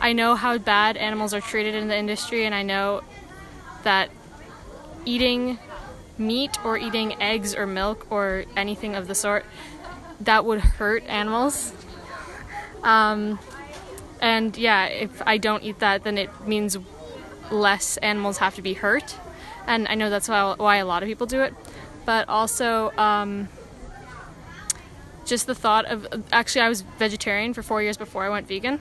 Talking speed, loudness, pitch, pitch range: 160 wpm, -23 LUFS, 215 Hz, 205-225 Hz